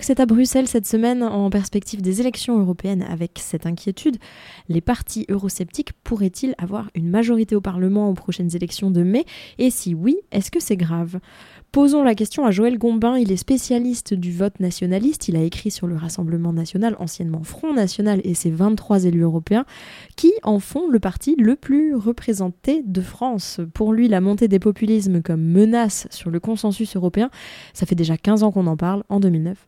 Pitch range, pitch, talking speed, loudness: 180-235 Hz, 205 Hz, 190 wpm, -20 LUFS